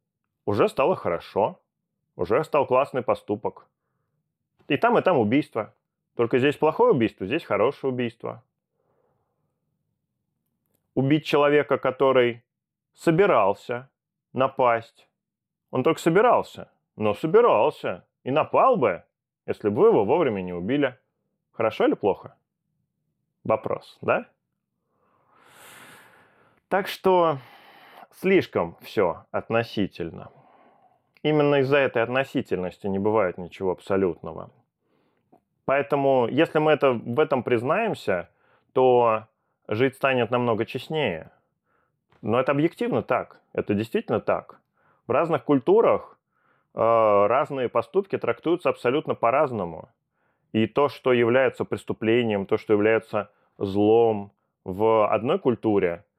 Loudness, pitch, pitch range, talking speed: -23 LUFS, 125 Hz, 110-145 Hz, 105 wpm